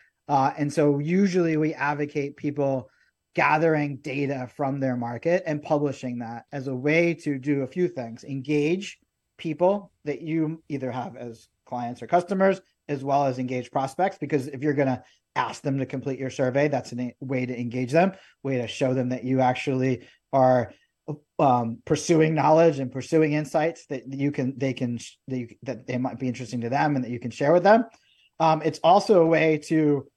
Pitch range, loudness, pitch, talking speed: 130-155 Hz, -25 LUFS, 140 Hz, 190 wpm